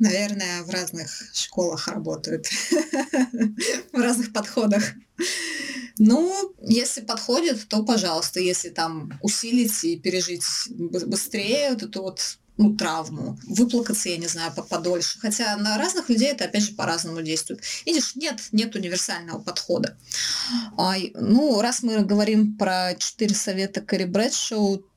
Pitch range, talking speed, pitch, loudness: 185-240 Hz, 125 wpm, 210 Hz, -23 LUFS